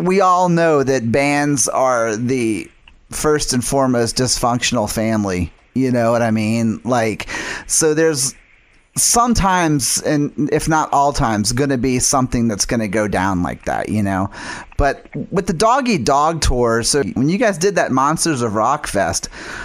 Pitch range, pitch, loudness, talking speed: 115-150 Hz, 130 Hz, -16 LUFS, 160 wpm